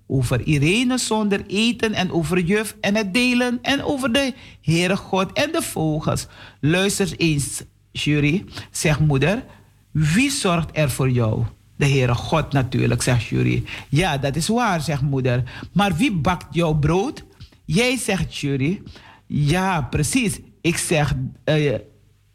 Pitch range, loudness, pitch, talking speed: 130-195 Hz, -21 LUFS, 155 Hz, 140 wpm